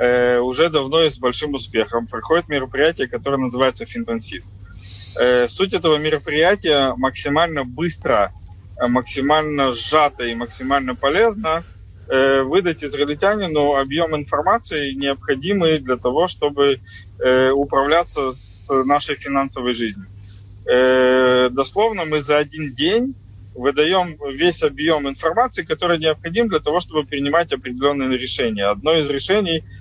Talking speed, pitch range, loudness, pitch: 110 wpm, 125-155 Hz, -18 LUFS, 140 Hz